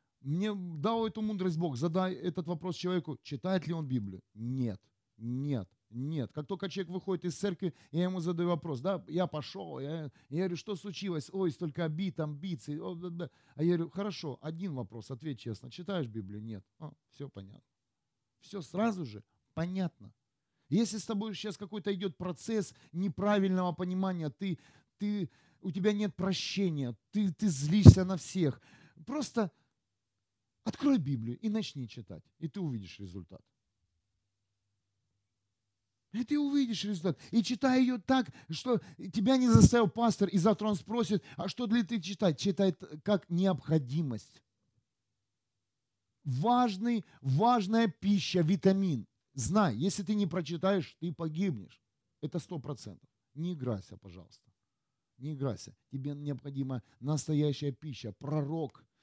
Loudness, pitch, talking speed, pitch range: -32 LUFS, 165 Hz, 140 wpm, 125-195 Hz